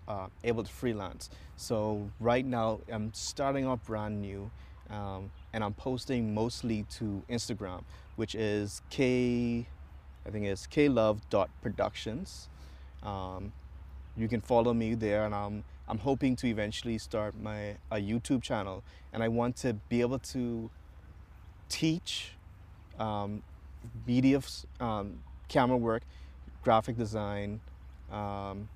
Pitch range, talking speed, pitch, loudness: 90-115 Hz, 130 wpm, 105 Hz, -33 LUFS